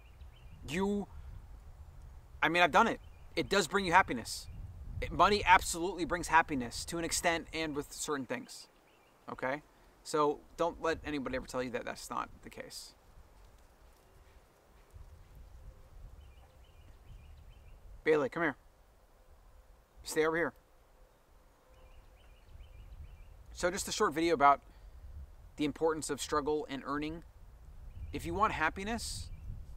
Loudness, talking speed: -33 LUFS, 115 wpm